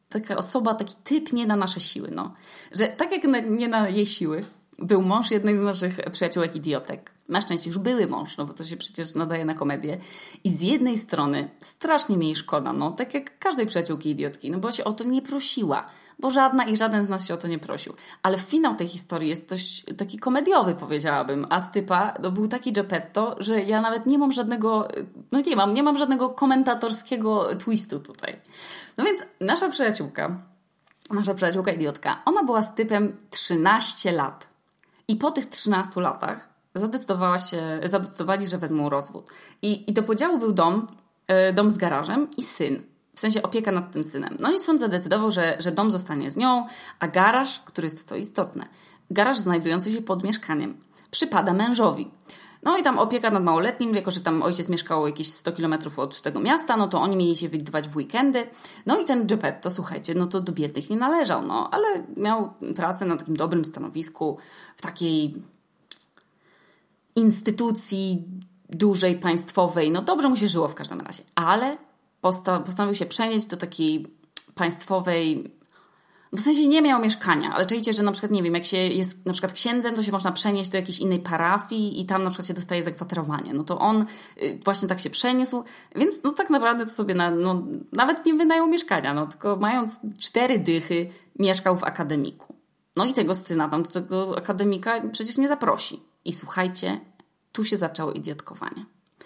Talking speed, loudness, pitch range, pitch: 185 wpm, -24 LUFS, 175-230 Hz, 195 Hz